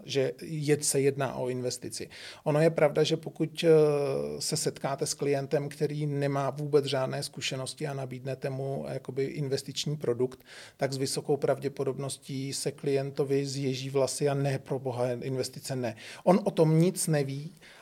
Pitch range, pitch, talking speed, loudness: 135-150 Hz, 140 Hz, 150 wpm, -30 LUFS